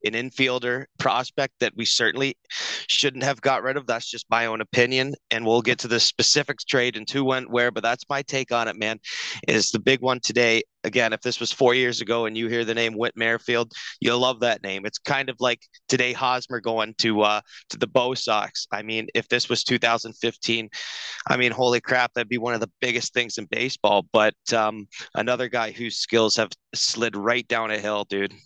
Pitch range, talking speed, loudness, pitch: 115-125 Hz, 215 wpm, -23 LUFS, 120 Hz